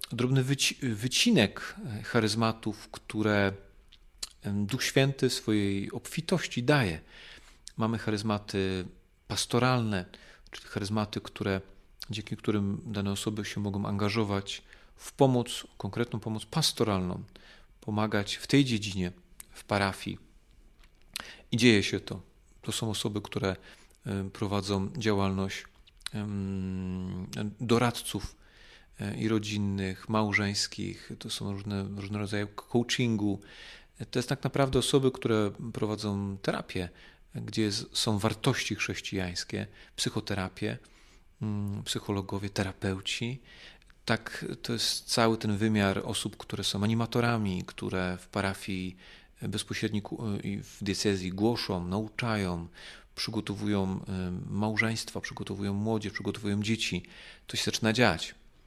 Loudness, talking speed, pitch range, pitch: -31 LUFS, 100 wpm, 100-115 Hz, 105 Hz